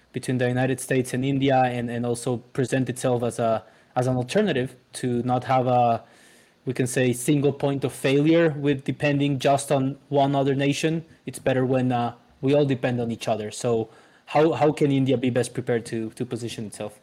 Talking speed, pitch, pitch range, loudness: 195 wpm, 130 Hz, 120-140 Hz, -24 LUFS